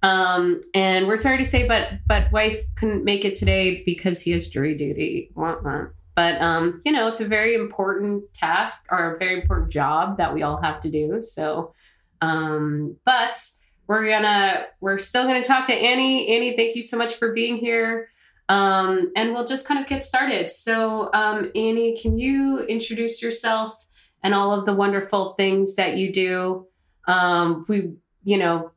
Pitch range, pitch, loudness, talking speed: 180-230 Hz, 200 Hz, -21 LUFS, 180 wpm